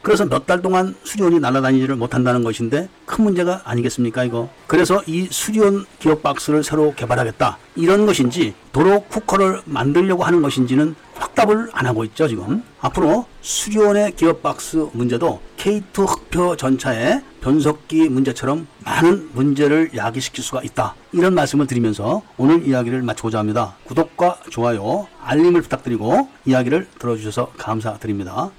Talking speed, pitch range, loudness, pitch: 370 characters per minute, 125-180 Hz, -18 LUFS, 150 Hz